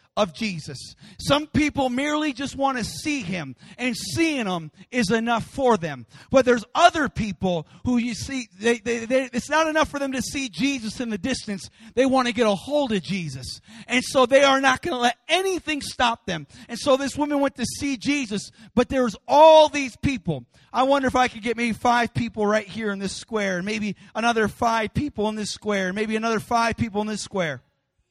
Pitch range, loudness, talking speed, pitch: 205-270 Hz, -23 LUFS, 205 wpm, 235 Hz